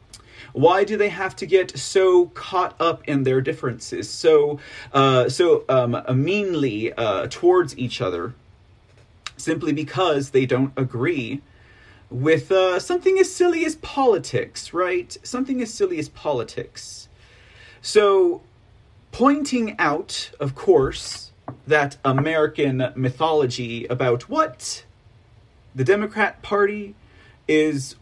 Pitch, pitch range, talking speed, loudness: 150 Hz, 125-205 Hz, 115 wpm, -21 LUFS